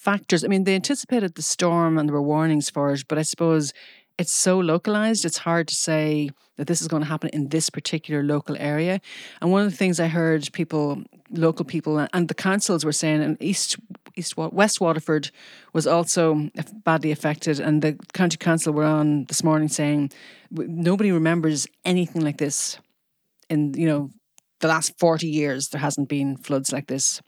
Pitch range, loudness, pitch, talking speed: 150-175 Hz, -22 LUFS, 160 Hz, 185 wpm